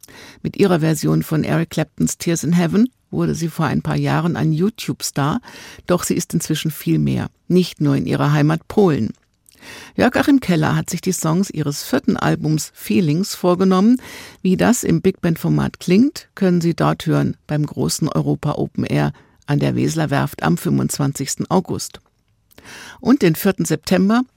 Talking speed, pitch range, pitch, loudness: 165 wpm, 150-190 Hz, 170 Hz, -18 LUFS